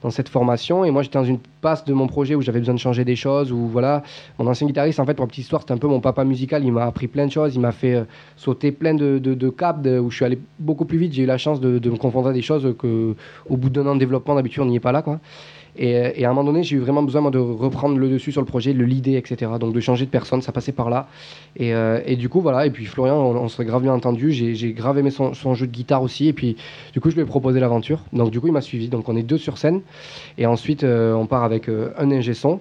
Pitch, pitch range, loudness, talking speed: 130 Hz, 125-145 Hz, -20 LUFS, 315 wpm